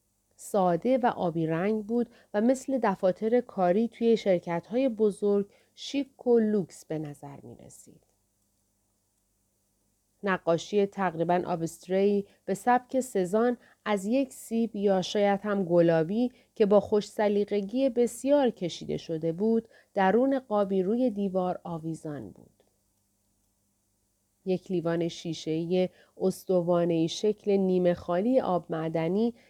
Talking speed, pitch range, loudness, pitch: 115 wpm, 165-220 Hz, -28 LUFS, 190 Hz